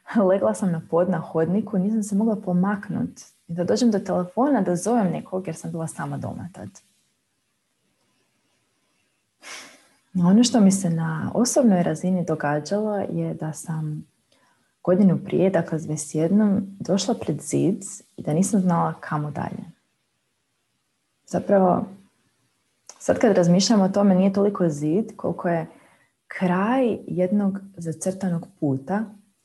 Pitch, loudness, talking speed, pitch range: 185 Hz, -23 LUFS, 130 wpm, 170-205 Hz